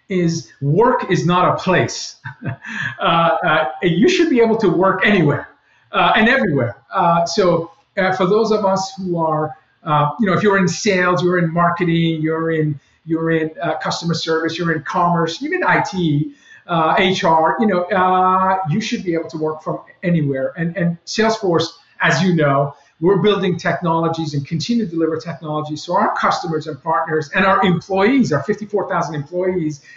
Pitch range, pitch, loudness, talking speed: 160-190 Hz, 170 Hz, -17 LUFS, 175 wpm